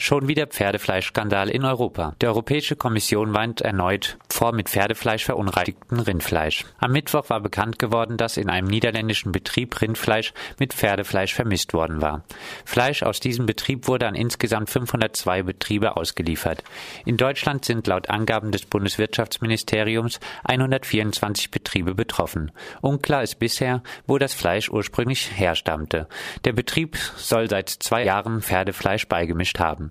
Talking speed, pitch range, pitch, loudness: 135 wpm, 95-120 Hz, 110 Hz, -23 LUFS